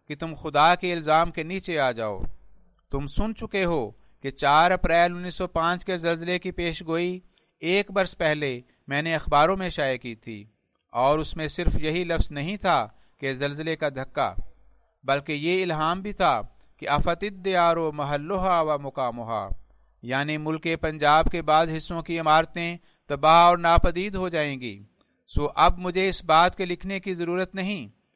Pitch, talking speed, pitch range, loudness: 165 Hz, 175 wpm, 145-180 Hz, -24 LUFS